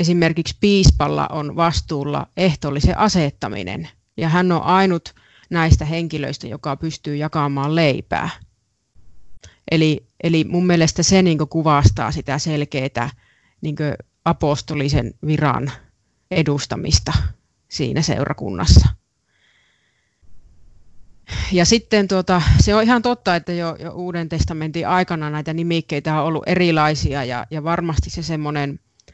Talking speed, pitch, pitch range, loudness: 110 wpm, 155 Hz, 145-170 Hz, -19 LUFS